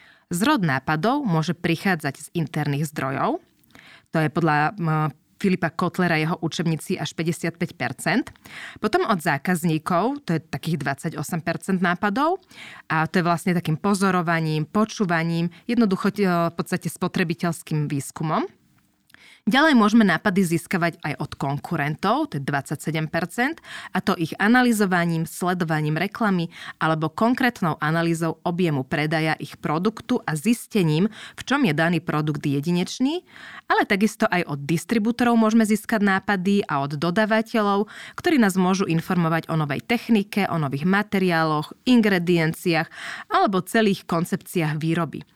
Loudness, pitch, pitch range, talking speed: -23 LUFS, 175 Hz, 160-205 Hz, 125 wpm